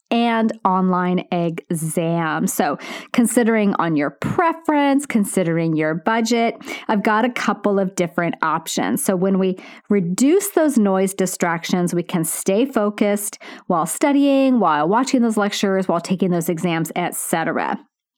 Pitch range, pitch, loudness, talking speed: 180-235 Hz, 200 Hz, -19 LUFS, 130 wpm